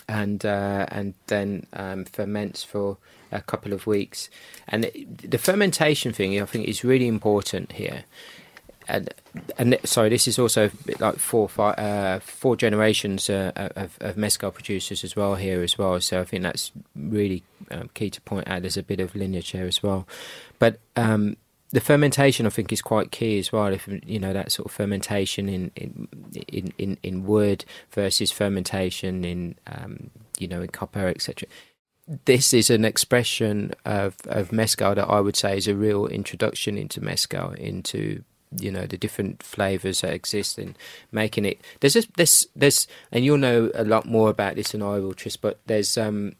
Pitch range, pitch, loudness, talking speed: 95-110 Hz, 105 Hz, -24 LUFS, 185 wpm